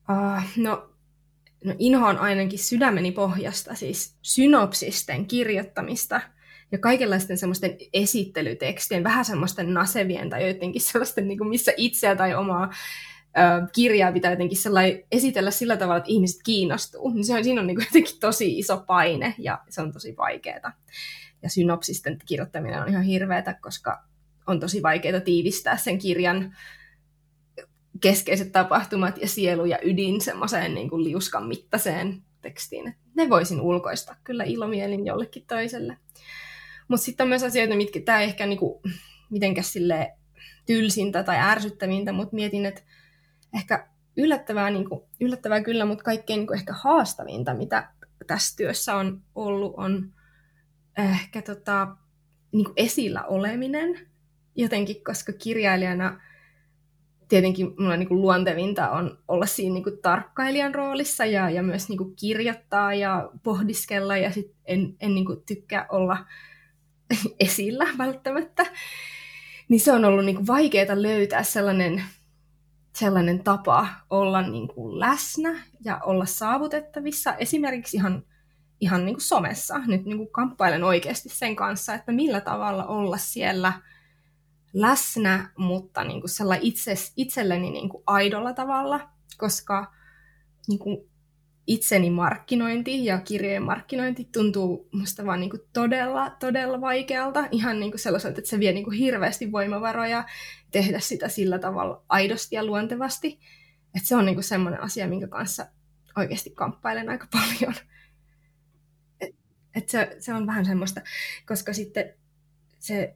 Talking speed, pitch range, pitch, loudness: 125 wpm, 180-225 Hz, 195 Hz, -24 LUFS